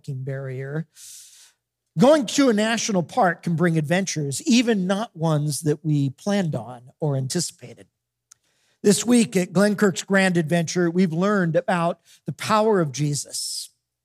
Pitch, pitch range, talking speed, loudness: 170 Hz, 145-200 Hz, 130 wpm, -22 LUFS